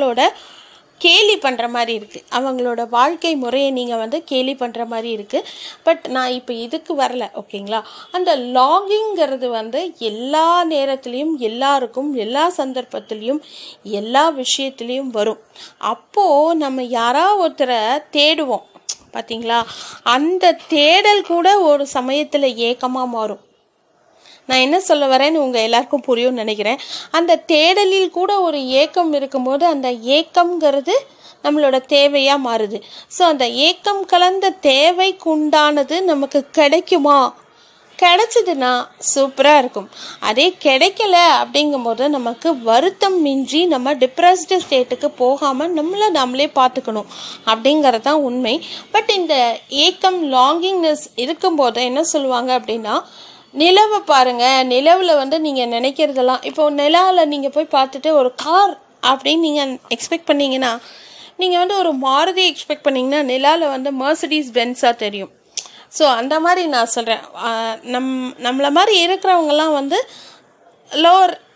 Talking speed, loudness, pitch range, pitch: 115 wpm, -15 LUFS, 250-330 Hz, 285 Hz